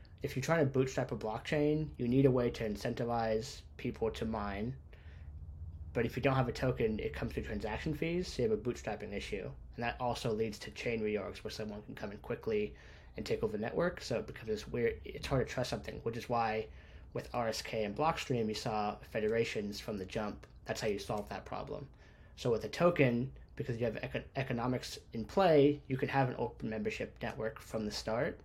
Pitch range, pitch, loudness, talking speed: 105-135 Hz, 115 Hz, -36 LUFS, 210 wpm